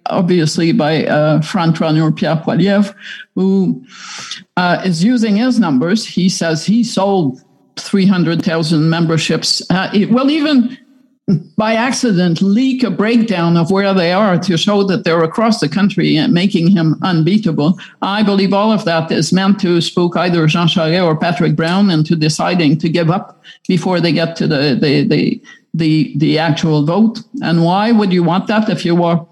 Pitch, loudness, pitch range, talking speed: 185 Hz, -13 LUFS, 165-210 Hz, 170 wpm